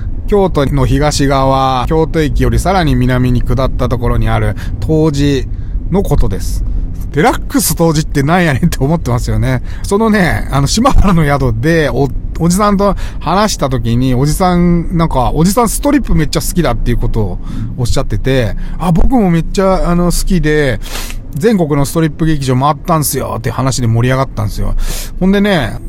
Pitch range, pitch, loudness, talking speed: 120-170 Hz, 140 Hz, -13 LUFS, 360 characters per minute